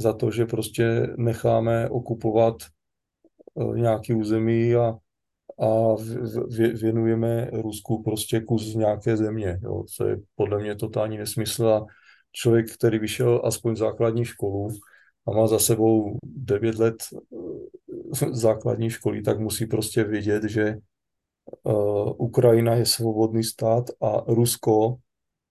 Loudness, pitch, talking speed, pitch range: -24 LUFS, 115 Hz, 120 wpm, 110-115 Hz